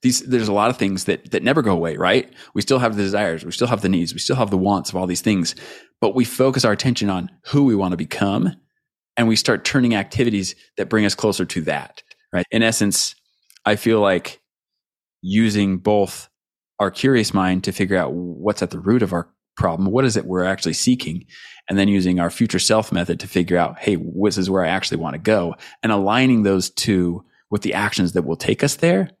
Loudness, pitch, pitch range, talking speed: -19 LUFS, 100 Hz, 95-115 Hz, 230 wpm